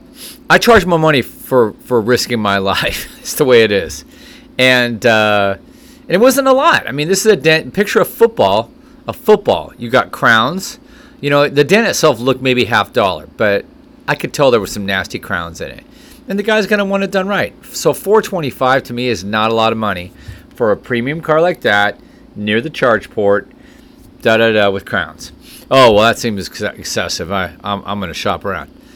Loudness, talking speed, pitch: -13 LUFS, 210 wpm, 130 Hz